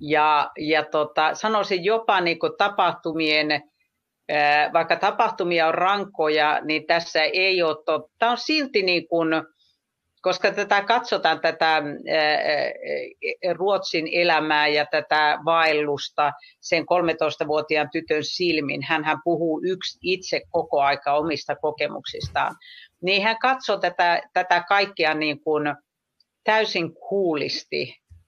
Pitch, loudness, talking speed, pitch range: 165 Hz, -22 LUFS, 110 wpm, 155-190 Hz